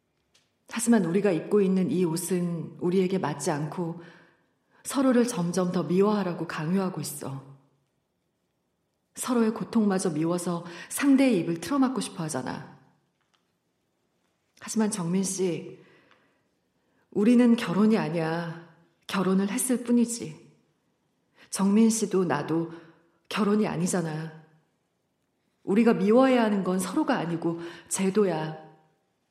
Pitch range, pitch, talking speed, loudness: 165-210 Hz, 185 Hz, 240 characters per minute, -26 LUFS